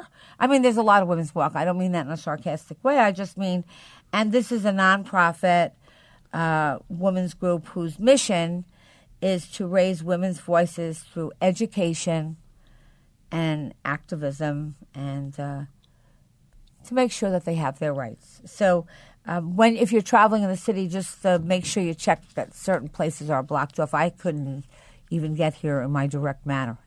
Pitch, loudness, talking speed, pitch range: 170 Hz, -24 LUFS, 175 wpm, 155-190 Hz